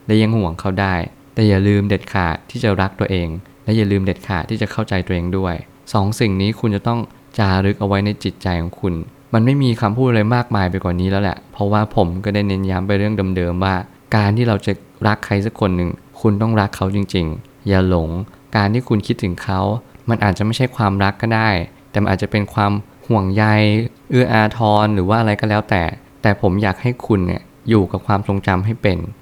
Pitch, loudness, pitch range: 100 Hz, -18 LUFS, 95-110 Hz